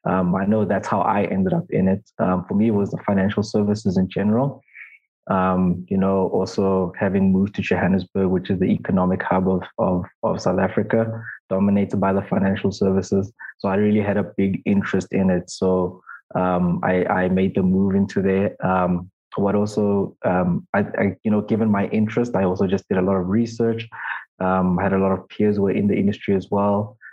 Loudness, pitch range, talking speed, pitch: -21 LUFS, 95-105 Hz, 210 wpm, 95 Hz